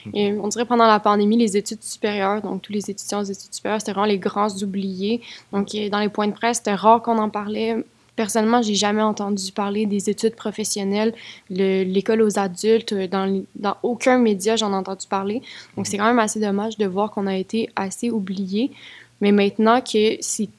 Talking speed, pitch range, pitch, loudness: 200 wpm, 200-225 Hz, 210 Hz, -21 LUFS